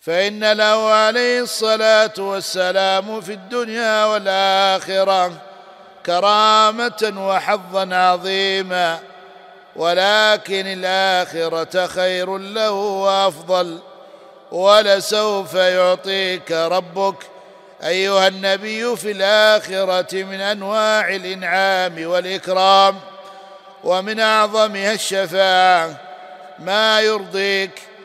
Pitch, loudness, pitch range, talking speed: 195 Hz, -17 LUFS, 185-210 Hz, 70 wpm